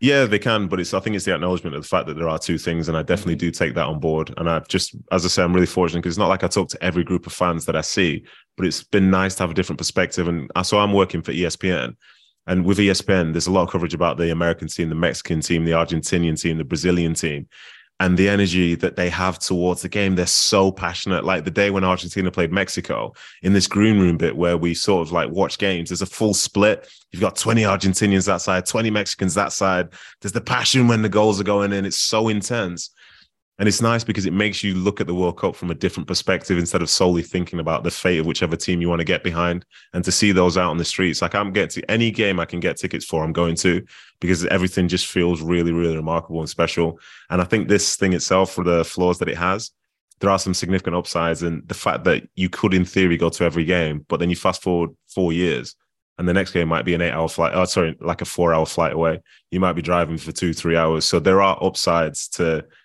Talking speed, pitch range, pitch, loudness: 255 wpm, 85-95 Hz, 90 Hz, -20 LUFS